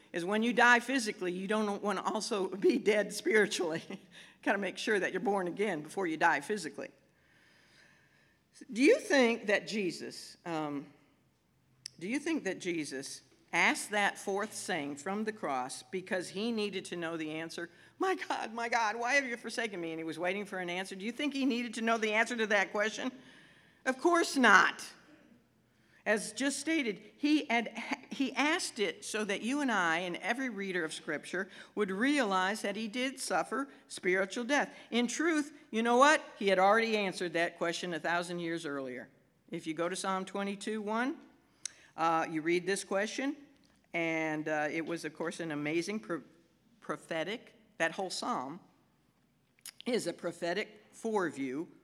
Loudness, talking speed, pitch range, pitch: -33 LUFS, 175 wpm, 170-240 Hz, 205 Hz